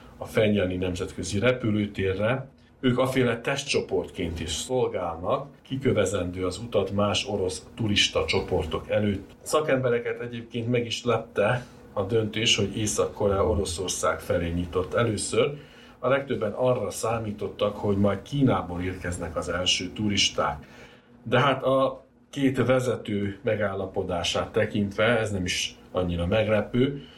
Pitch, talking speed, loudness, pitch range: 105 Hz, 115 wpm, -26 LUFS, 95-120 Hz